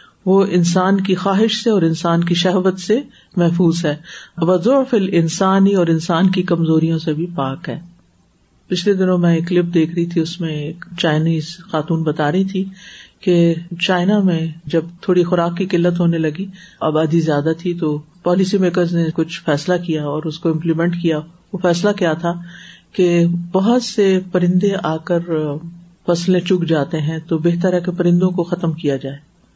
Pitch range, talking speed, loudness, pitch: 160-185 Hz, 175 wpm, -17 LUFS, 175 Hz